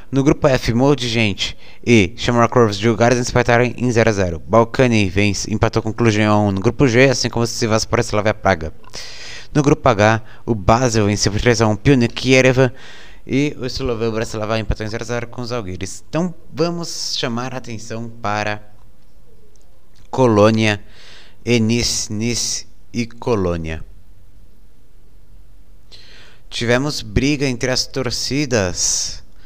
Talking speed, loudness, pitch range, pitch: 145 wpm, -17 LUFS, 105-125 Hz, 115 Hz